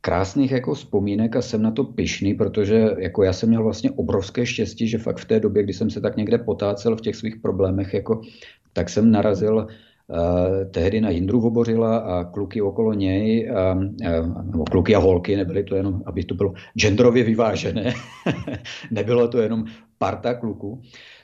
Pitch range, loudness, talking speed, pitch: 95-115 Hz, -21 LUFS, 175 wpm, 110 Hz